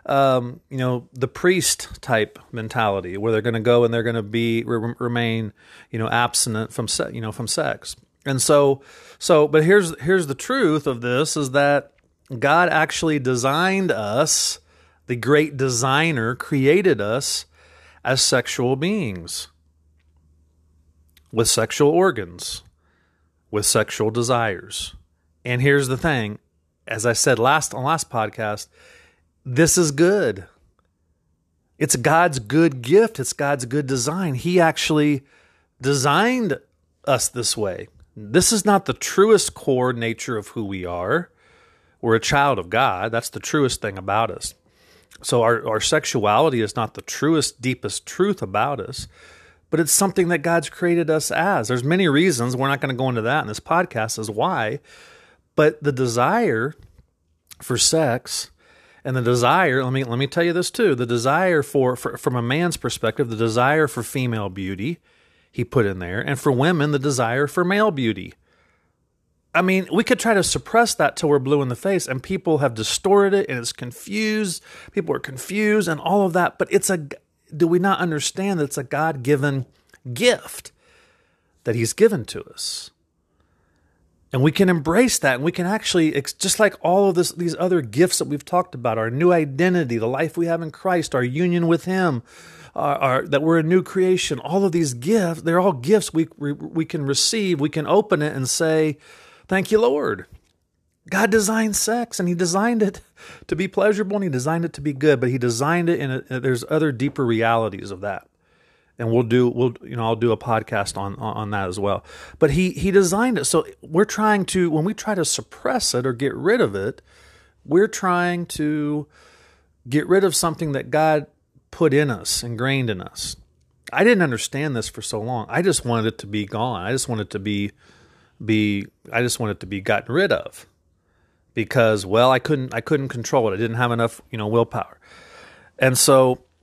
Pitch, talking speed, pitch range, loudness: 135 Hz, 185 wpm, 115-170 Hz, -20 LUFS